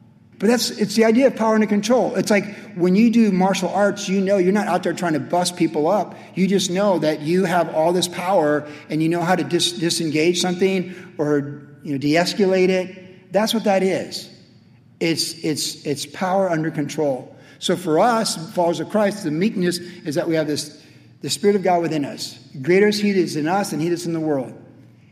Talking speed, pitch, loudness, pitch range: 215 wpm, 175 Hz, -20 LUFS, 155-195 Hz